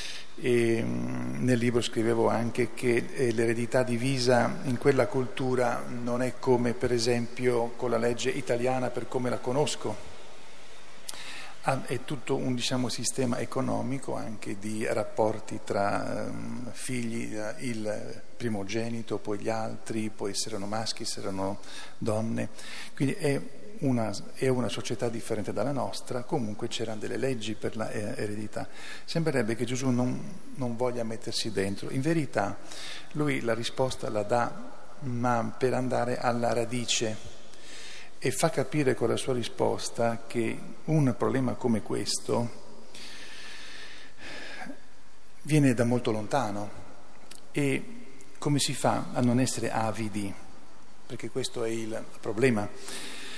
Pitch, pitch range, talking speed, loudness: 120 Hz, 110-130 Hz, 125 wpm, -30 LUFS